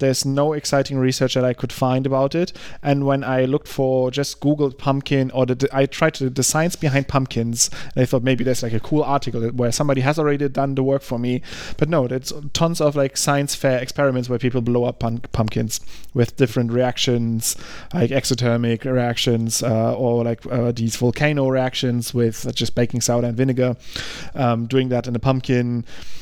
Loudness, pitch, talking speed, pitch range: -20 LUFS, 130 Hz, 195 wpm, 120-140 Hz